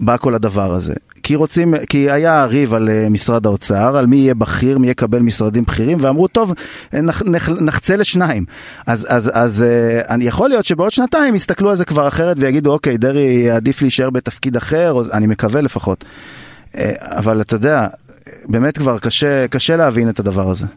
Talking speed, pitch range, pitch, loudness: 180 wpm, 115-155 Hz, 130 Hz, -14 LUFS